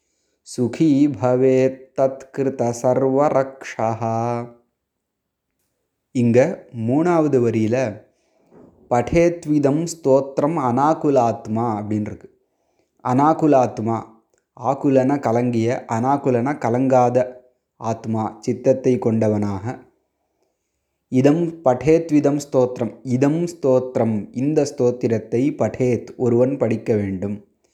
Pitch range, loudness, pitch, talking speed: 115-135 Hz, -19 LUFS, 125 Hz, 60 wpm